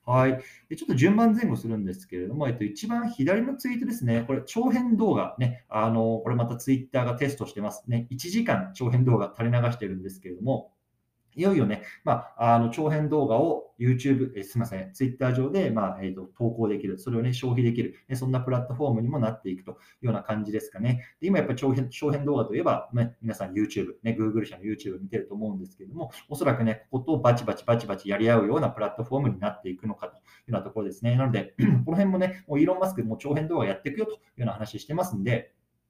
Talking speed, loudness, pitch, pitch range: 520 characters per minute, -27 LUFS, 120 Hz, 110-140 Hz